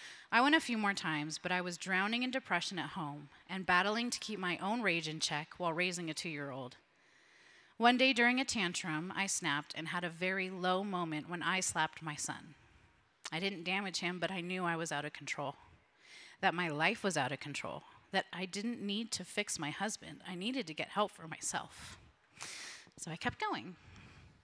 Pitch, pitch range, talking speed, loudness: 180 Hz, 155-200 Hz, 210 wpm, -36 LUFS